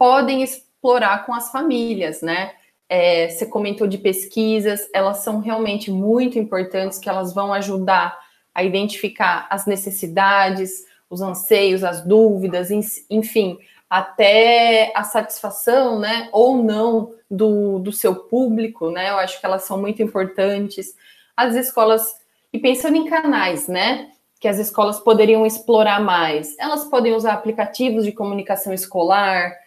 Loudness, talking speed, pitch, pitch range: -18 LUFS, 135 wpm, 210 Hz, 195-230 Hz